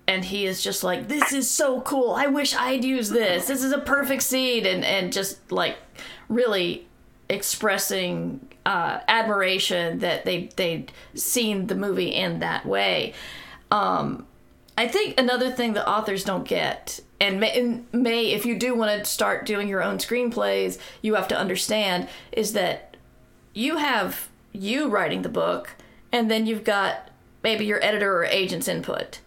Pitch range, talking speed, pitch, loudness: 195-250 Hz, 160 wpm, 220 Hz, -24 LUFS